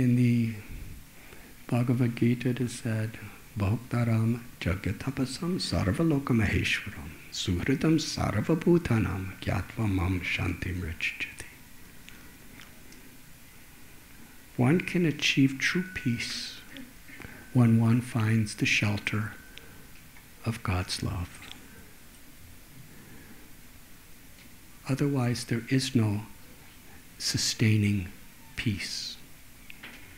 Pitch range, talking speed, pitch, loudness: 100-130 Hz, 70 wpm, 115 Hz, -28 LUFS